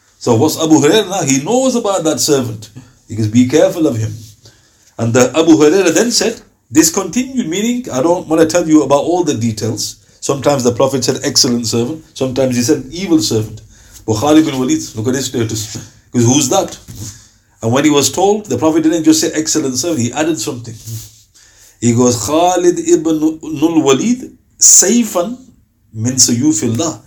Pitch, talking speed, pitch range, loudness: 135 Hz, 170 wpm, 115-170 Hz, -12 LUFS